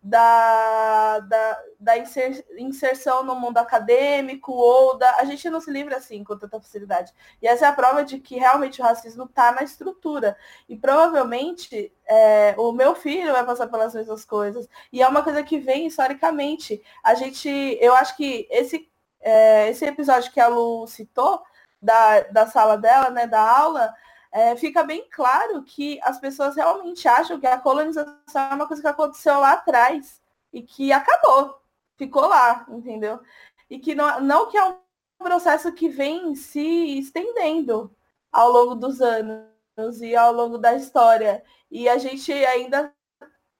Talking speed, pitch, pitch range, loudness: 165 wpm, 260 Hz, 230-295 Hz, -19 LUFS